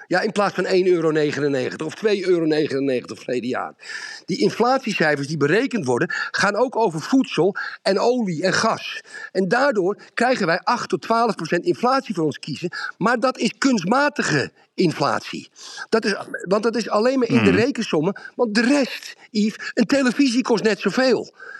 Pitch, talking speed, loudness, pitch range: 220 Hz, 165 wpm, -20 LUFS, 175-250 Hz